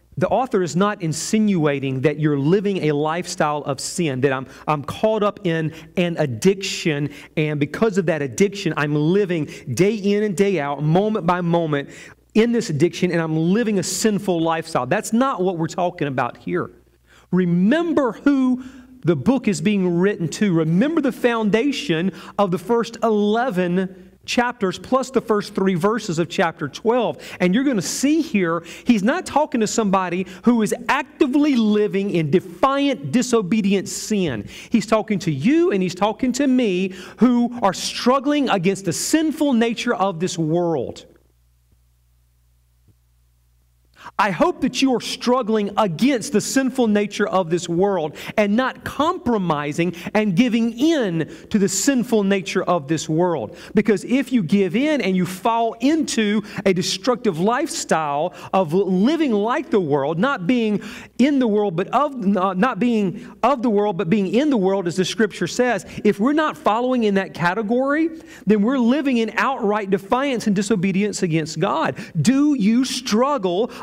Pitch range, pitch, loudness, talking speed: 175-240 Hz, 200 Hz, -20 LUFS, 160 wpm